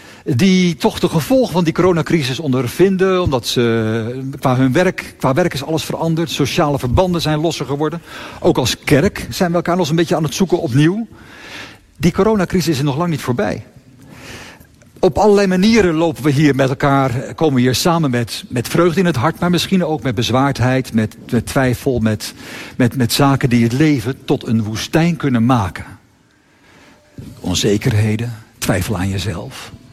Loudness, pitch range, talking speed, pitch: -16 LUFS, 125-175 Hz, 170 wpm, 145 Hz